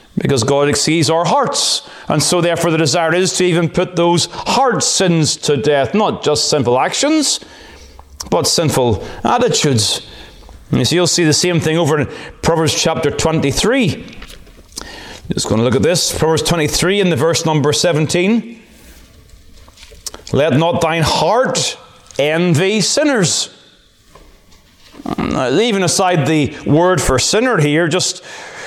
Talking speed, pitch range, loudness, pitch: 140 wpm, 145-180 Hz, -14 LUFS, 165 Hz